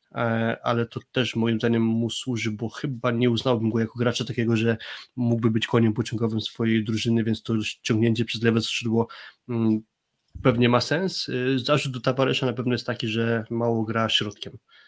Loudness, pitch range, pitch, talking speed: -24 LUFS, 115-125 Hz, 115 Hz, 170 wpm